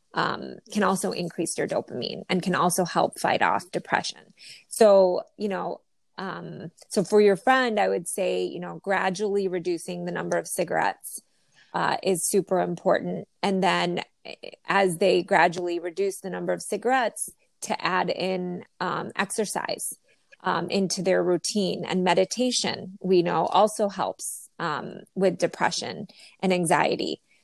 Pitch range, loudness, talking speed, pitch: 175-200 Hz, -25 LUFS, 145 wpm, 190 Hz